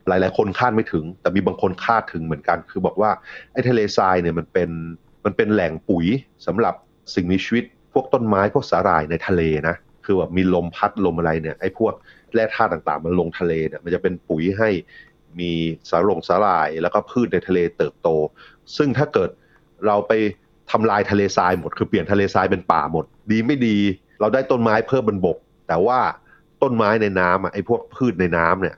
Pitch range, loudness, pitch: 85-105 Hz, -20 LUFS, 95 Hz